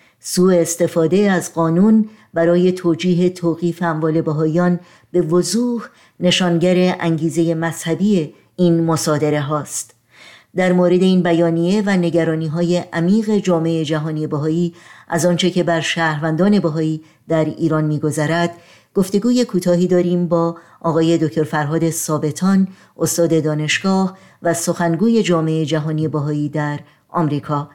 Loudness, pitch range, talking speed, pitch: -17 LUFS, 160-180 Hz, 115 wpm, 170 Hz